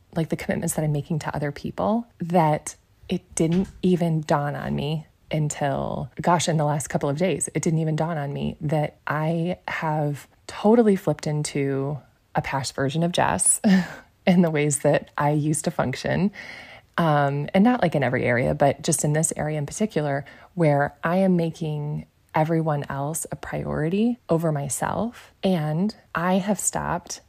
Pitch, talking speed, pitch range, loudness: 155 Hz, 170 wpm, 145-180 Hz, -24 LUFS